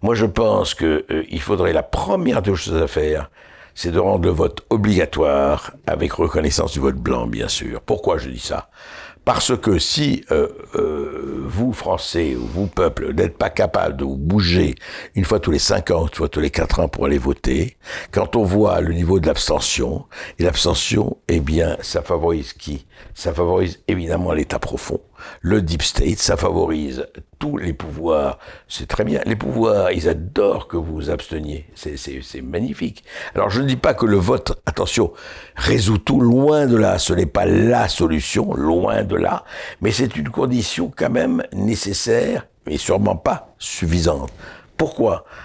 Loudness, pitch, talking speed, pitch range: -19 LUFS, 90 Hz, 180 wpm, 80-110 Hz